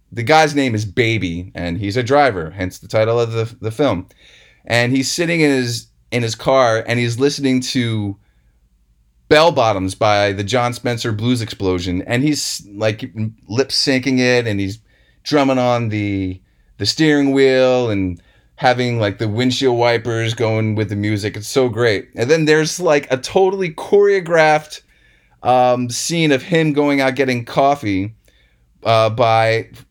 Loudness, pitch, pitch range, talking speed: -16 LUFS, 120 Hz, 105-135 Hz, 160 wpm